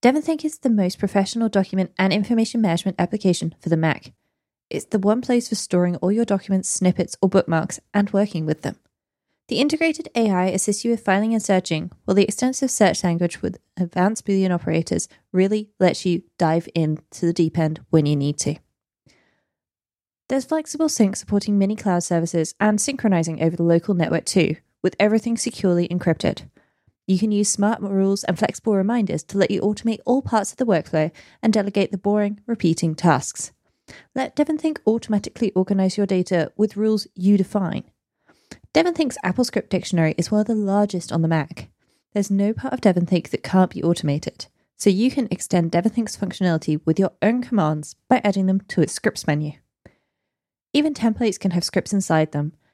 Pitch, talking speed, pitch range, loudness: 195 Hz, 175 wpm, 170-215 Hz, -21 LUFS